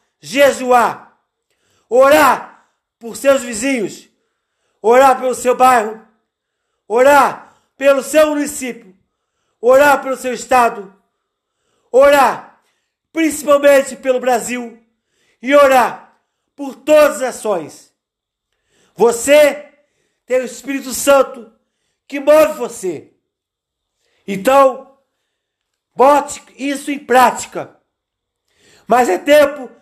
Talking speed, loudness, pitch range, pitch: 85 wpm, -13 LUFS, 245-295 Hz, 275 Hz